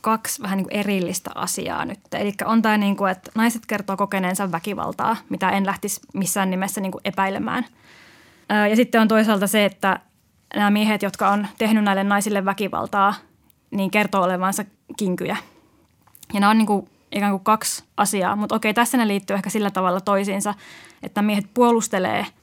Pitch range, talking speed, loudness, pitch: 195-215 Hz, 170 wpm, -21 LUFS, 205 Hz